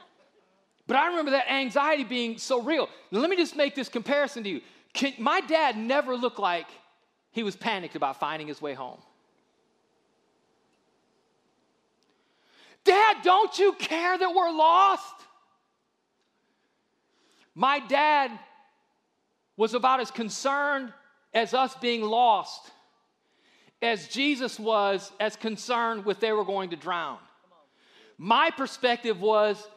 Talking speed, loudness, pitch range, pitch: 125 wpm, -26 LUFS, 220-320 Hz, 260 Hz